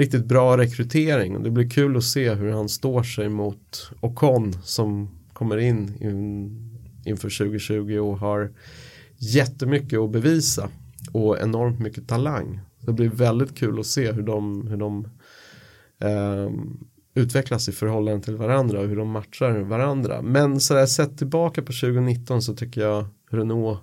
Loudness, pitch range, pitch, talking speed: -23 LUFS, 105-130 Hz, 115 Hz, 150 wpm